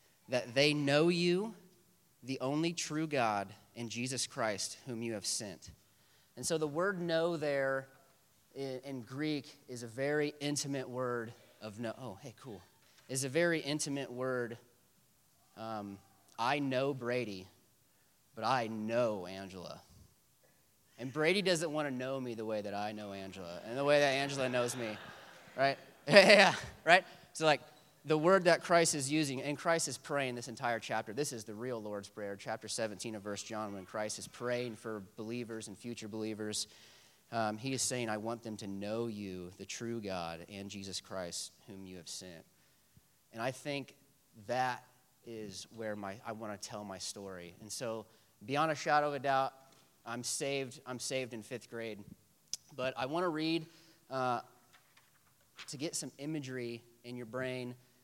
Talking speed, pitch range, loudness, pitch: 170 wpm, 110-140 Hz, -35 LUFS, 125 Hz